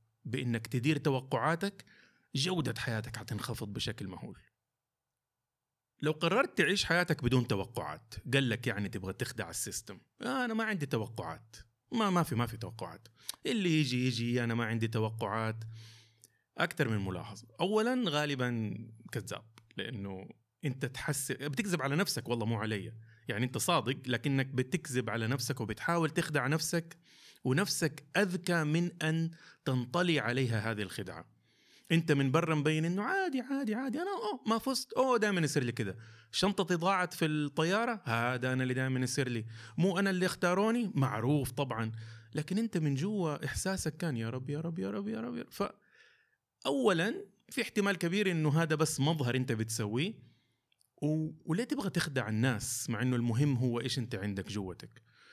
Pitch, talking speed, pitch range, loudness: 130 Hz, 155 wpm, 115-170 Hz, -33 LUFS